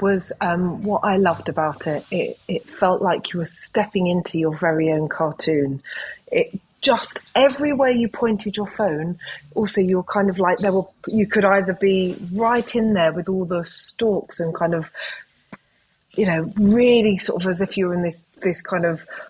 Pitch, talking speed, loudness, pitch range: 190 Hz, 195 wpm, -20 LUFS, 170-210 Hz